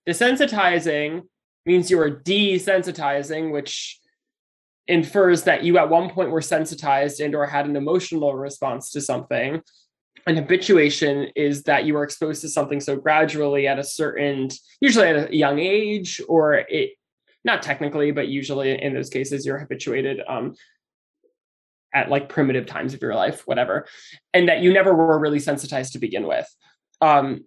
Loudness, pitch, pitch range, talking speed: -21 LUFS, 155 Hz, 140-180 Hz, 155 wpm